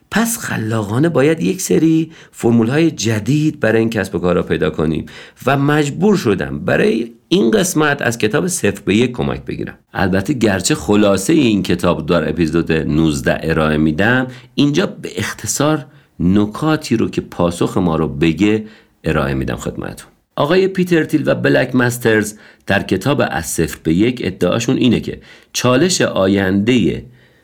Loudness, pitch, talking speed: -16 LUFS, 115 Hz, 150 wpm